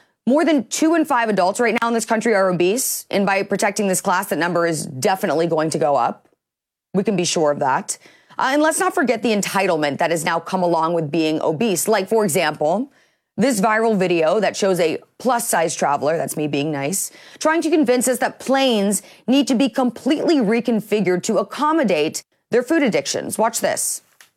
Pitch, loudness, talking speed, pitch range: 210 Hz, -19 LUFS, 200 wpm, 170-255 Hz